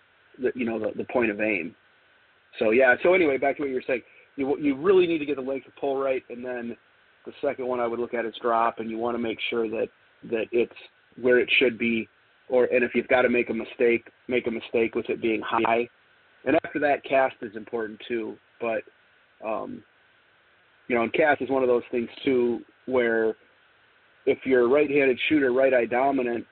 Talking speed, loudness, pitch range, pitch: 220 wpm, -25 LUFS, 115-180 Hz, 125 Hz